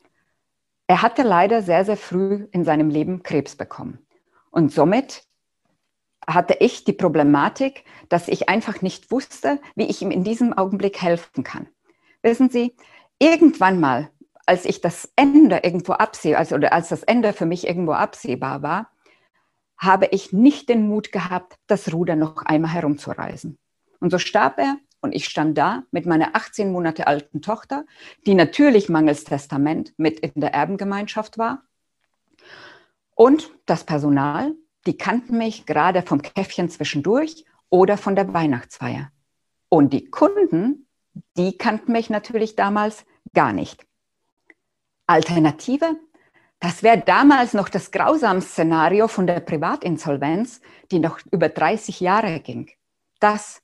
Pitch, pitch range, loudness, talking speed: 190 Hz, 160-230 Hz, -20 LUFS, 140 wpm